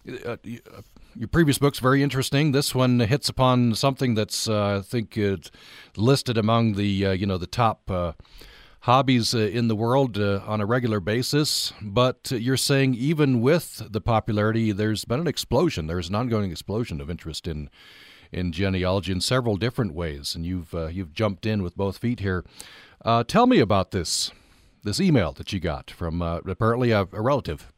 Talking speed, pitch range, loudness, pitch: 185 wpm, 95-125 Hz, -24 LUFS, 110 Hz